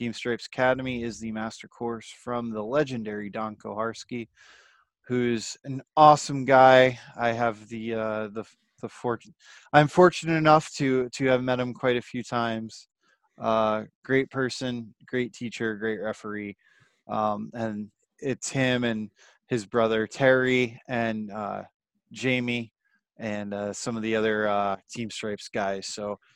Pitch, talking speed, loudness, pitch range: 115 Hz, 145 wpm, -26 LUFS, 110-130 Hz